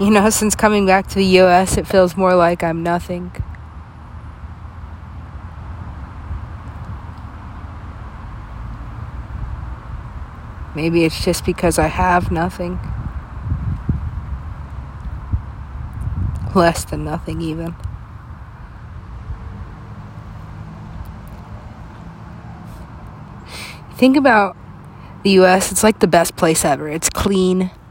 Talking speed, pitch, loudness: 80 wpm, 110 Hz, -16 LUFS